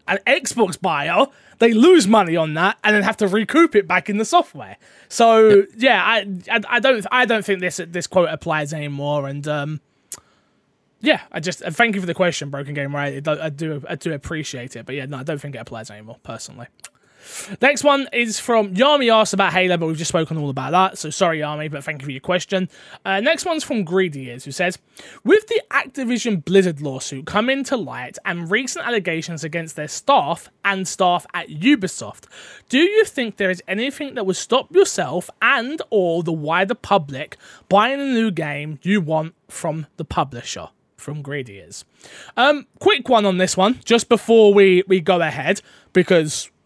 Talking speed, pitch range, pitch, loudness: 190 wpm, 155-230 Hz, 185 Hz, -18 LUFS